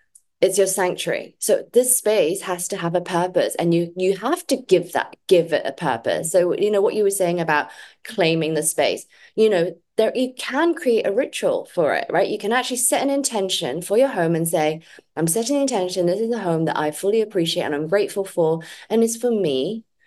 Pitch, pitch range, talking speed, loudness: 195 Hz, 170-230 Hz, 225 wpm, -21 LUFS